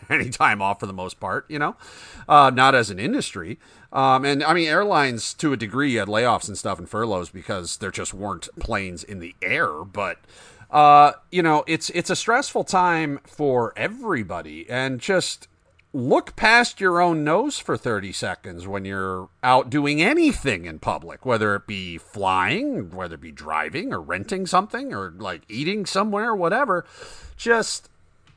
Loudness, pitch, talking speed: -21 LUFS, 145 Hz, 170 wpm